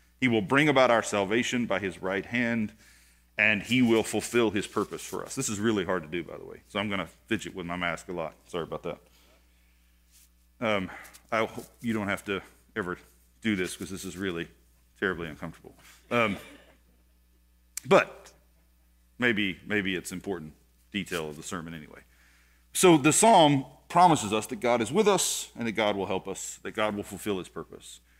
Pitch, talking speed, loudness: 95 Hz, 190 wpm, -27 LUFS